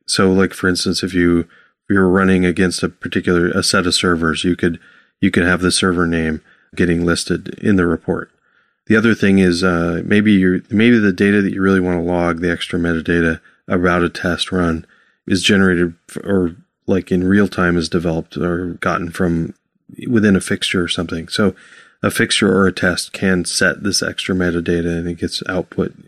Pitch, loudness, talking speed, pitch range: 90 Hz, -16 LUFS, 195 wpm, 85-95 Hz